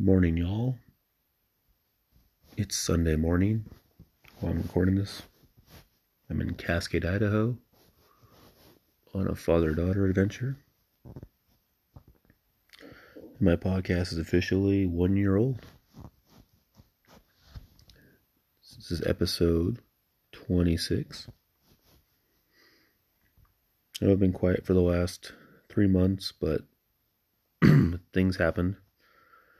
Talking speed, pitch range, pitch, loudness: 85 wpm, 85-105 Hz, 95 Hz, -28 LUFS